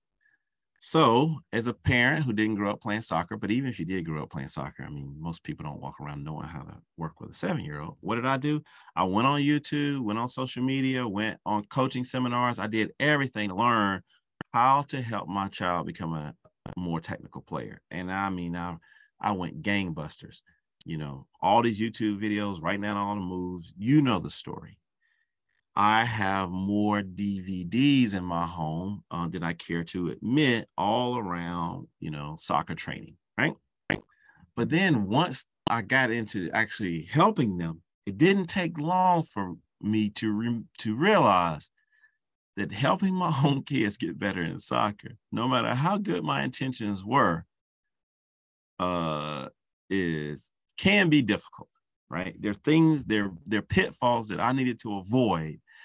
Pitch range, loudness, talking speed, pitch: 90-130 Hz, -28 LUFS, 175 wpm, 105 Hz